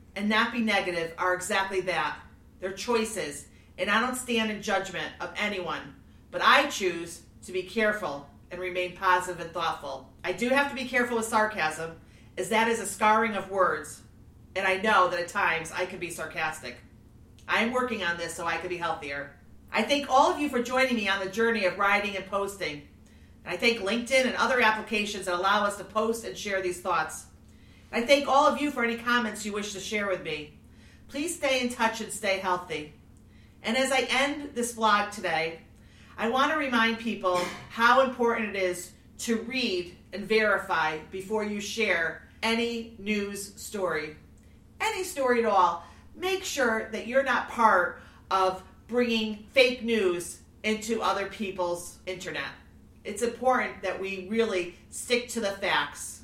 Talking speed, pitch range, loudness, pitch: 180 wpm, 180-235 Hz, -27 LUFS, 205 Hz